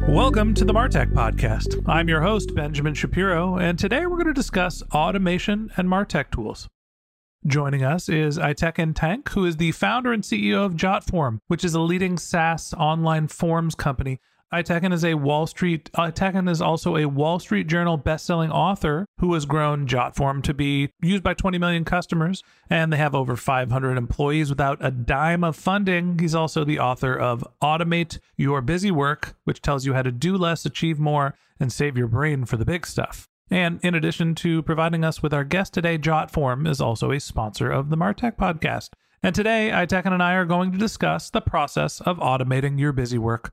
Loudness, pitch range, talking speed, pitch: -22 LUFS, 140-180 Hz, 190 wpm, 160 Hz